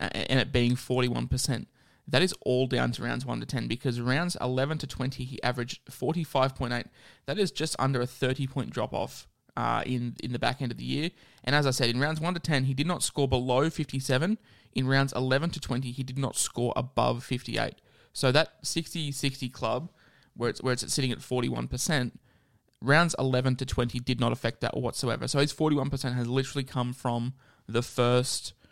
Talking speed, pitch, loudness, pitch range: 200 wpm, 130 Hz, -29 LUFS, 125-140 Hz